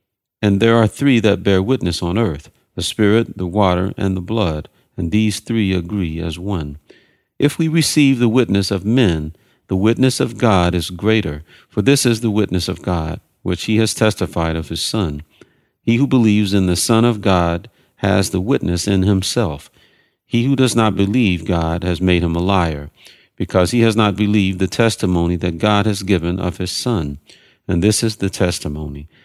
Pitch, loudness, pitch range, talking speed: 100 Hz, -17 LUFS, 90-115 Hz, 190 wpm